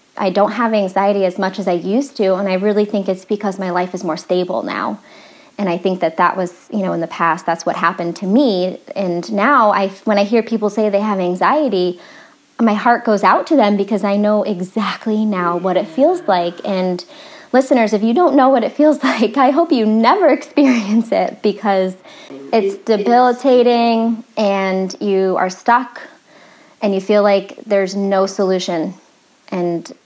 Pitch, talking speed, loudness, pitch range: 205 Hz, 190 wpm, -16 LUFS, 185-240 Hz